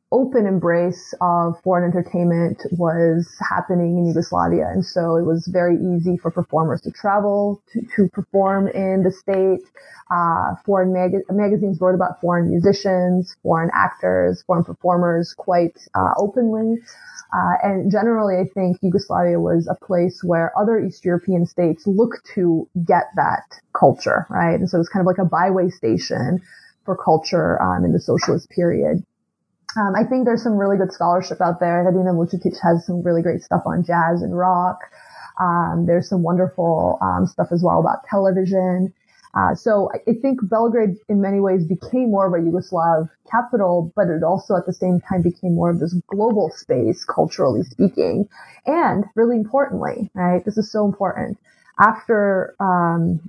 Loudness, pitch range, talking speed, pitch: -19 LUFS, 175-200 Hz, 165 wpm, 185 Hz